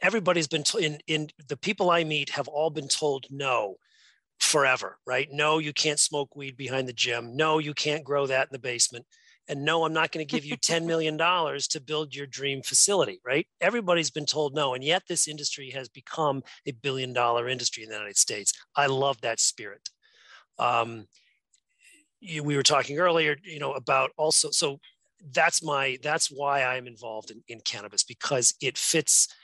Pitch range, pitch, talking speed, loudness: 130-160 Hz, 145 Hz, 190 wpm, -26 LUFS